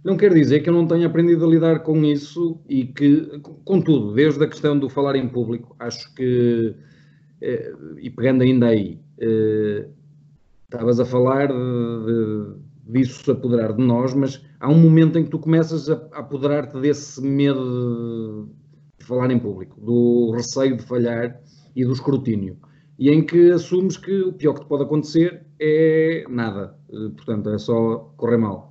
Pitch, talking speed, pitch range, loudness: 135 Hz, 165 wpm, 120-150 Hz, -19 LUFS